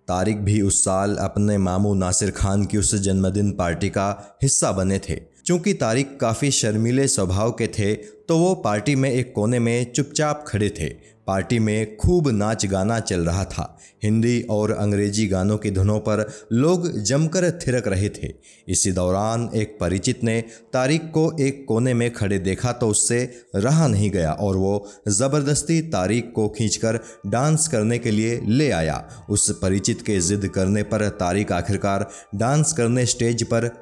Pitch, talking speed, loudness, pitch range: 105 Hz, 165 wpm, -21 LUFS, 100-120 Hz